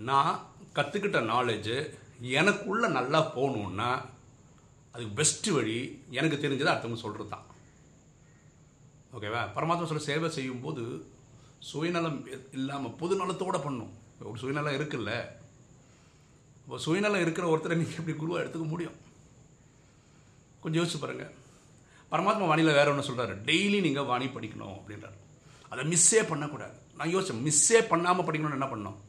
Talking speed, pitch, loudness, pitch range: 120 wpm, 145 Hz, -29 LUFS, 125-165 Hz